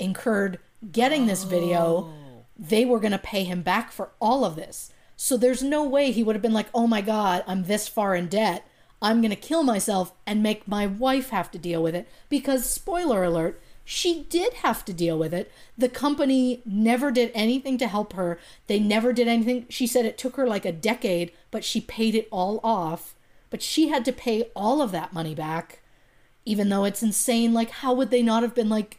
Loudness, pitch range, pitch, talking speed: -24 LUFS, 185-250 Hz, 220 Hz, 215 wpm